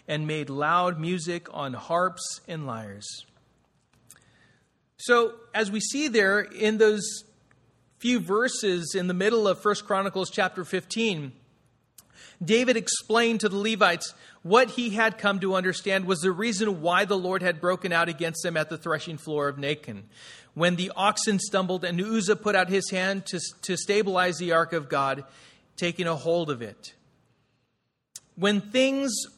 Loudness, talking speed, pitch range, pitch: -25 LUFS, 155 wpm, 165-210 Hz, 185 Hz